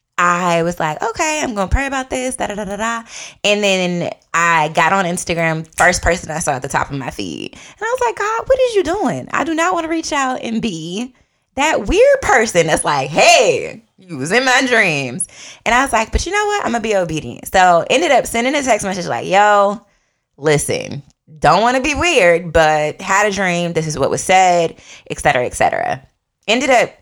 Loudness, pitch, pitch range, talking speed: -15 LUFS, 200 Hz, 170-260 Hz, 225 wpm